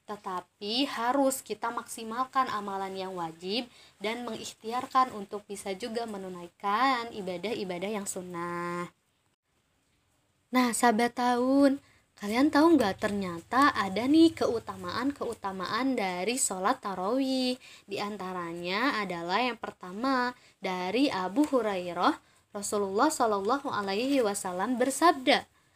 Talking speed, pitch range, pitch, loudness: 100 wpm, 195-255 Hz, 220 Hz, -29 LUFS